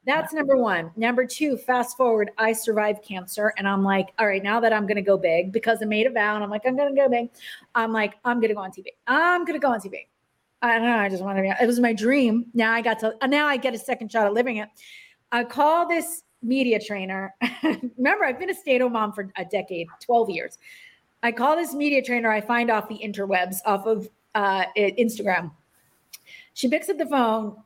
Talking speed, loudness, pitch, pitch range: 230 wpm, -23 LUFS, 230 Hz, 210-255 Hz